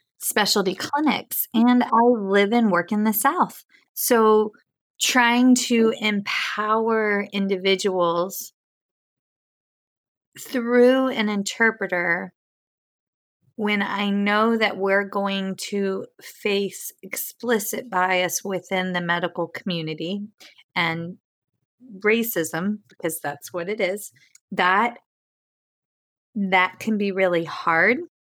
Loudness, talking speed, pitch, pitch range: -22 LUFS, 95 wpm, 205 Hz, 185-225 Hz